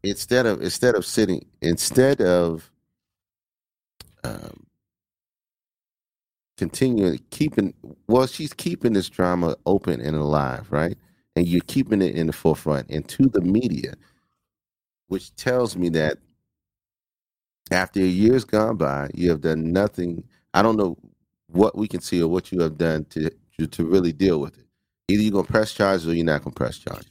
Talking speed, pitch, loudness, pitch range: 160 wpm, 90 Hz, -22 LUFS, 80-105 Hz